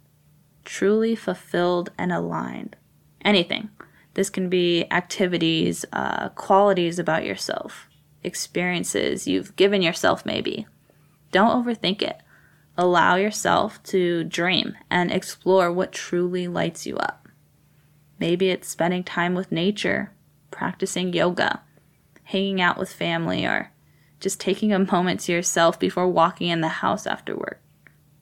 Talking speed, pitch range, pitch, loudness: 125 wpm, 165-190 Hz, 180 Hz, -23 LUFS